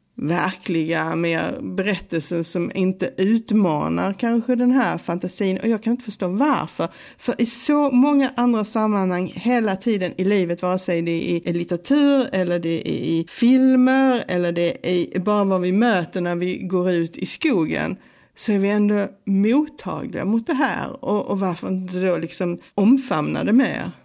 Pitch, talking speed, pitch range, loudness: 195 Hz, 170 wpm, 175-235 Hz, -21 LUFS